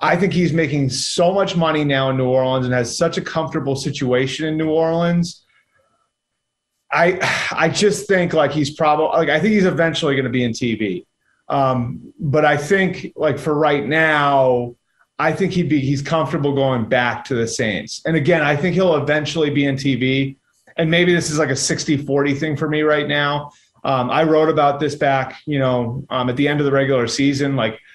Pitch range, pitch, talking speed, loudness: 135-160 Hz, 150 Hz, 205 wpm, -18 LUFS